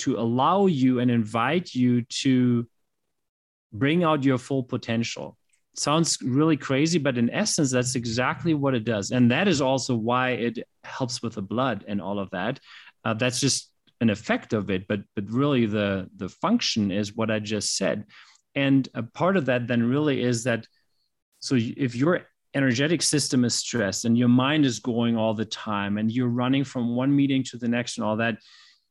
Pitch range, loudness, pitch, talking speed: 115-135 Hz, -24 LUFS, 125 Hz, 190 wpm